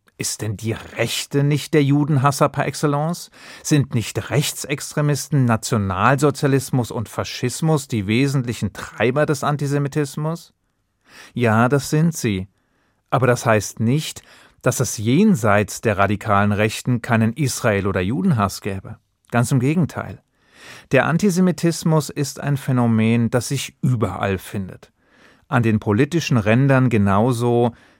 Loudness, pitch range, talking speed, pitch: -19 LUFS, 110-145 Hz, 120 wpm, 125 Hz